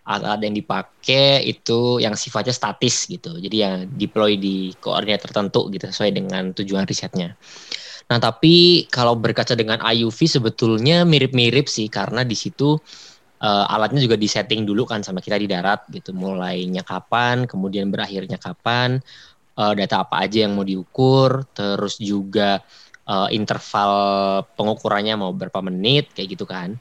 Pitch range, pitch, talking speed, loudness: 100-125 Hz, 110 Hz, 145 wpm, -19 LUFS